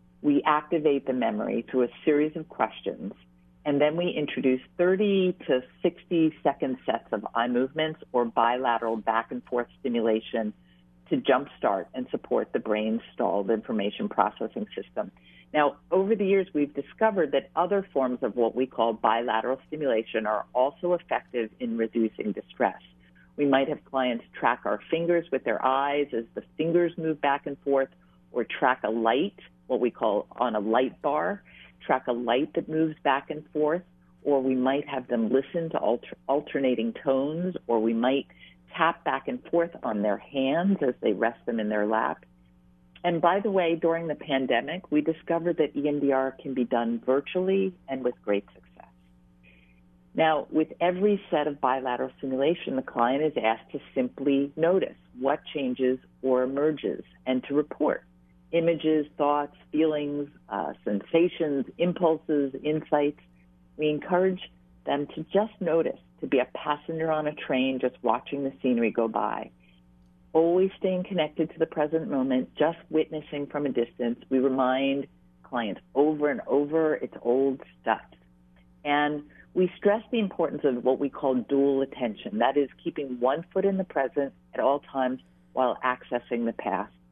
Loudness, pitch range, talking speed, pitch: -27 LUFS, 115-155 Hz, 160 wpm, 135 Hz